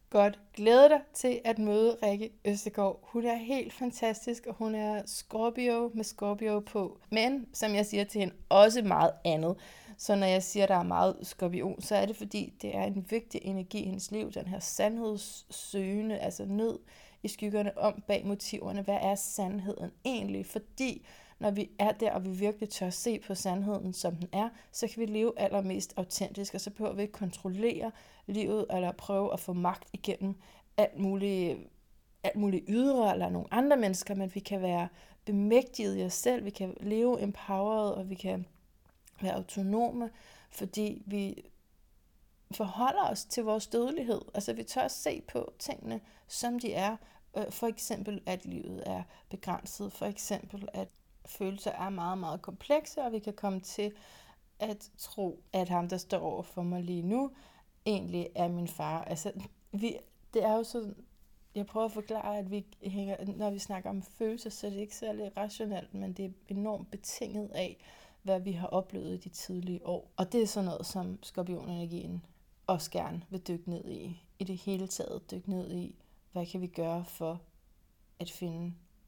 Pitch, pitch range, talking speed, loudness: 200 Hz, 185-215 Hz, 180 wpm, -33 LUFS